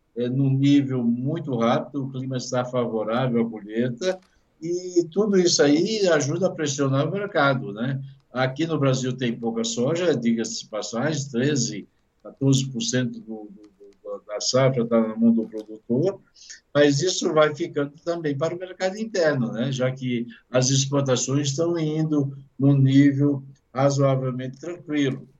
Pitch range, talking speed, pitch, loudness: 125-155 Hz, 145 wpm, 135 Hz, -23 LUFS